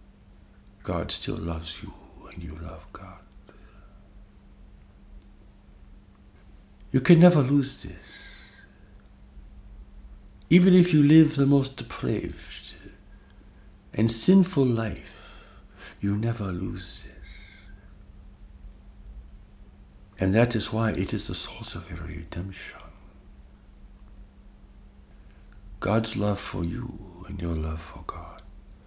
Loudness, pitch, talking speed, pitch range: -25 LUFS, 95 Hz, 100 wpm, 80-115 Hz